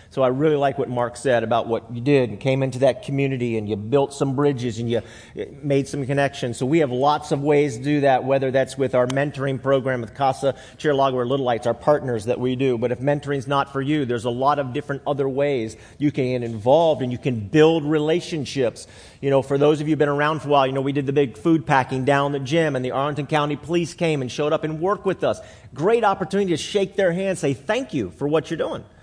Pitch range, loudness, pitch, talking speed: 125-150 Hz, -21 LUFS, 140 Hz, 255 wpm